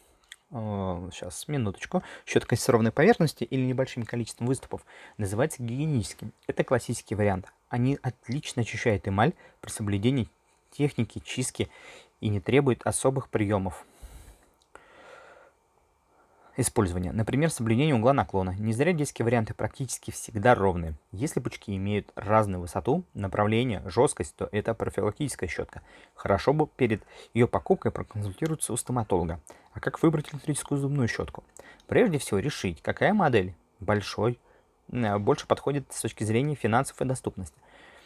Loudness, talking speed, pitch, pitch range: -28 LUFS, 125 wpm, 115 Hz, 100-135 Hz